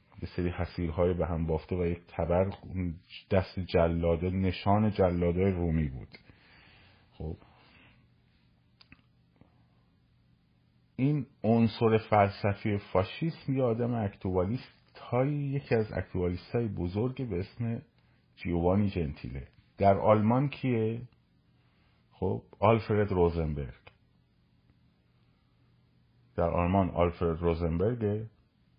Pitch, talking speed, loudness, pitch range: 95 Hz, 90 wpm, -30 LUFS, 85-110 Hz